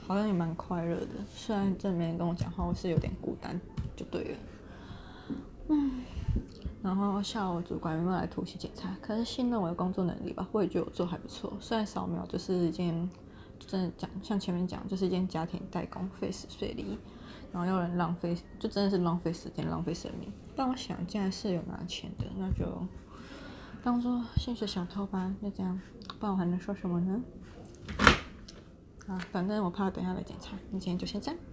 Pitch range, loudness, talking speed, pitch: 175-200 Hz, -34 LUFS, 295 characters per minute, 185 Hz